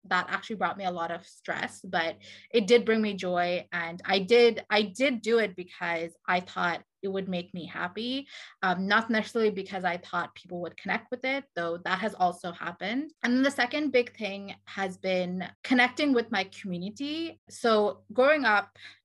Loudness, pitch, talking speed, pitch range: -28 LUFS, 195 Hz, 190 wpm, 180-235 Hz